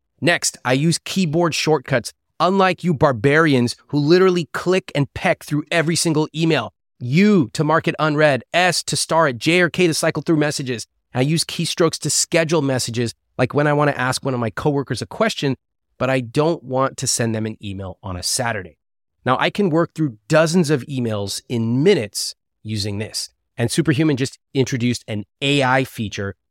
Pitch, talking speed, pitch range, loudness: 140 Hz, 185 wpm, 120-165 Hz, -19 LUFS